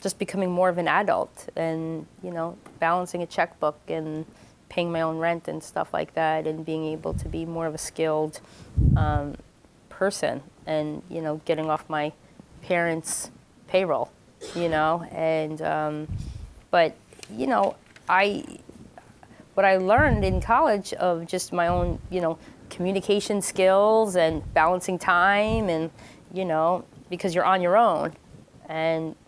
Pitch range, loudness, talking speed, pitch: 155-185 Hz, -25 LUFS, 150 wpm, 165 Hz